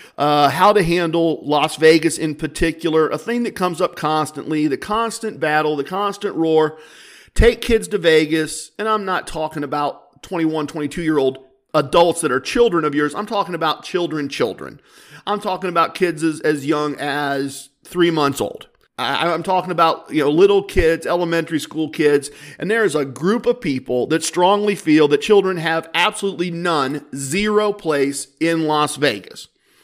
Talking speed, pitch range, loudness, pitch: 175 wpm, 150-185 Hz, -18 LUFS, 160 Hz